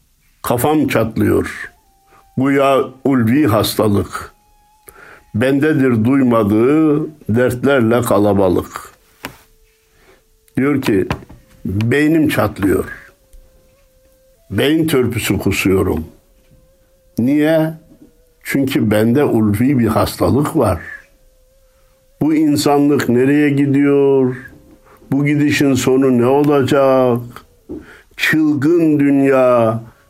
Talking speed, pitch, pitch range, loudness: 70 wpm, 135 Hz, 115-150 Hz, -14 LUFS